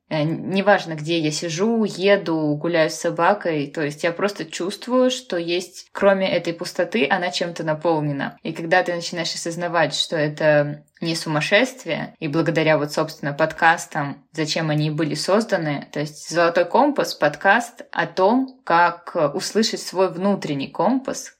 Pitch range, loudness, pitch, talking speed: 155-195 Hz, -21 LUFS, 170 Hz, 145 wpm